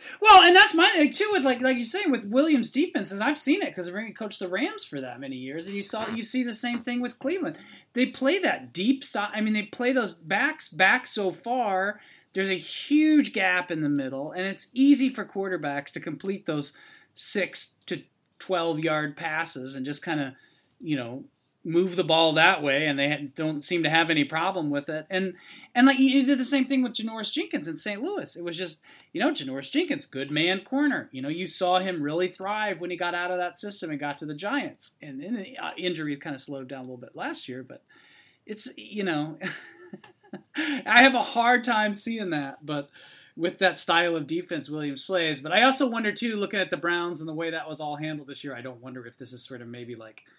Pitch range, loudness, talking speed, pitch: 155-255 Hz, -25 LUFS, 230 wpm, 185 Hz